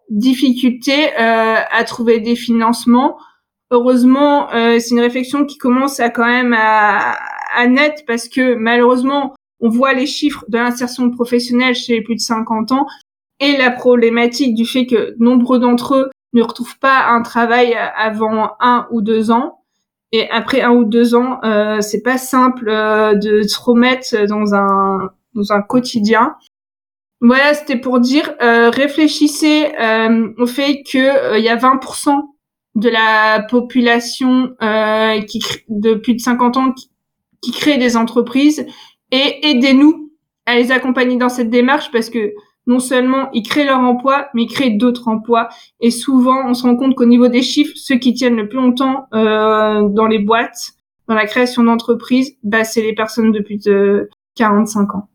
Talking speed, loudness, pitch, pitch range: 175 wpm, -13 LUFS, 240 Hz, 225-260 Hz